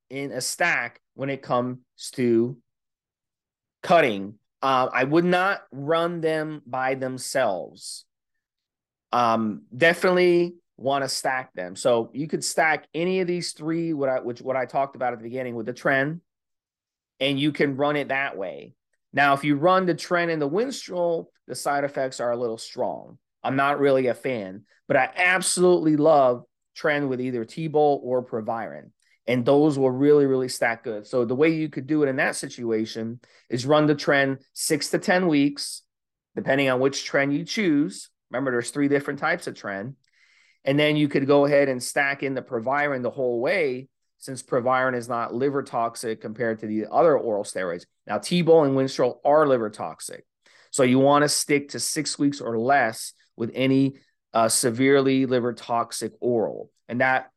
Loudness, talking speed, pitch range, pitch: -23 LUFS, 180 wpm, 125-150 Hz, 135 Hz